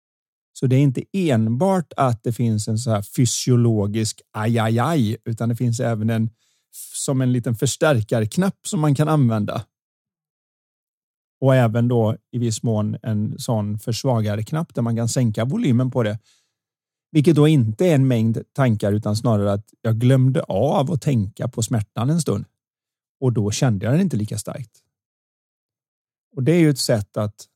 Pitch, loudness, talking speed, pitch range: 120 Hz, -20 LUFS, 170 wpm, 110-140 Hz